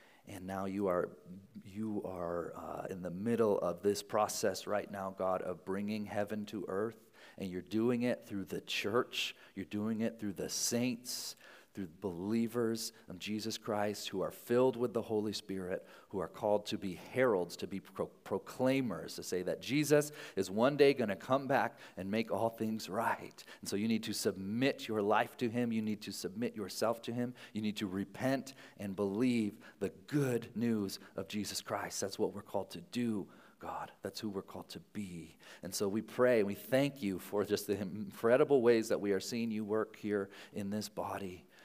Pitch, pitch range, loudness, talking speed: 105 Hz, 100-120 Hz, -36 LUFS, 195 wpm